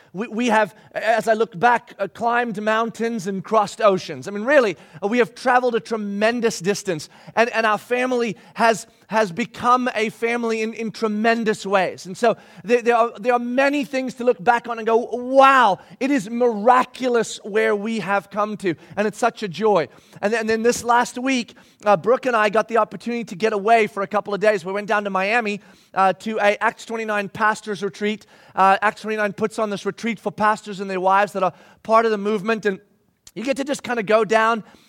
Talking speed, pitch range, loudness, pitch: 210 wpm, 205-235 Hz, -20 LUFS, 220 Hz